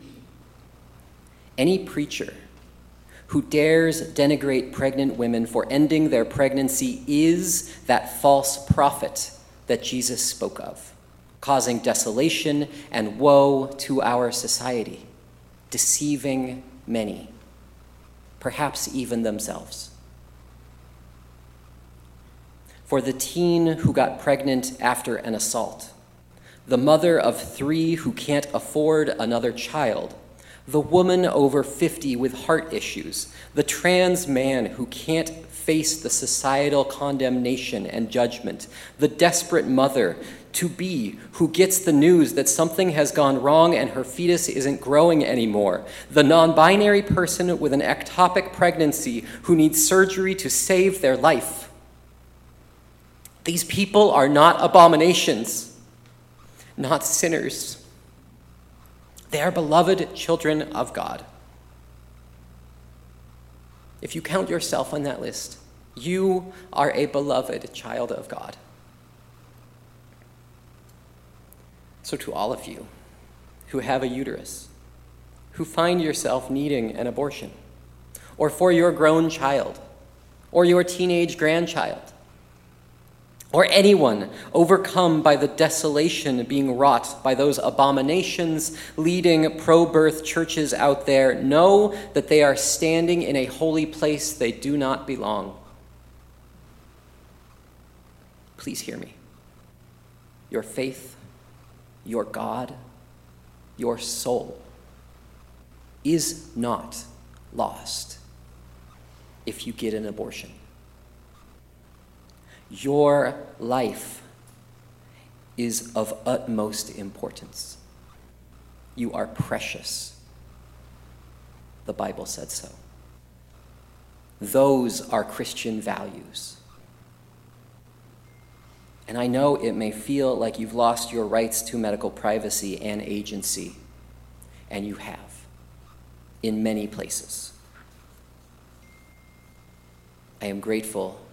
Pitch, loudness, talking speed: 115 Hz, -22 LUFS, 105 wpm